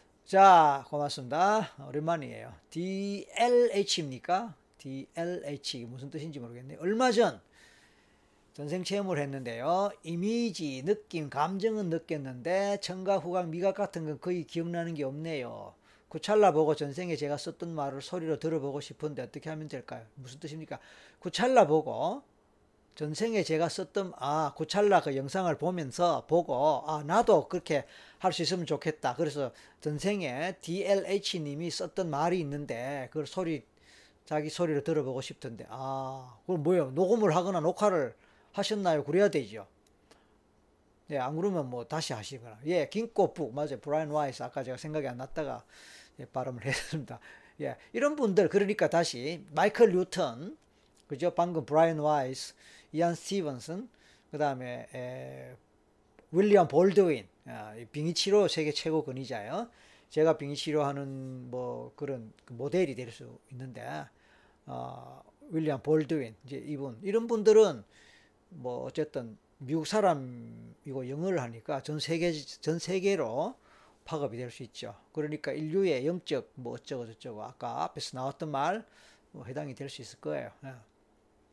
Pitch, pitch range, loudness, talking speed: 155 Hz, 140-180 Hz, -31 LUFS, 300 characters per minute